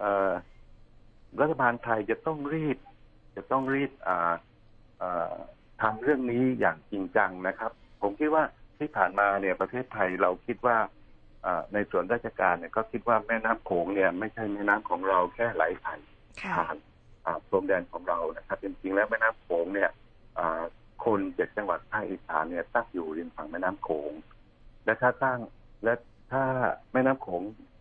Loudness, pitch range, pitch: -29 LUFS, 100-125 Hz, 110 Hz